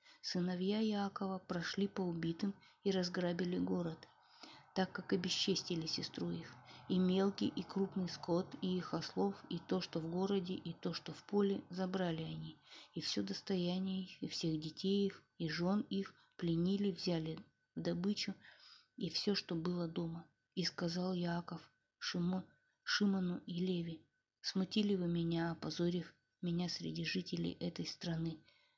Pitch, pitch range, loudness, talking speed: 180 Hz, 165-195 Hz, -40 LUFS, 145 wpm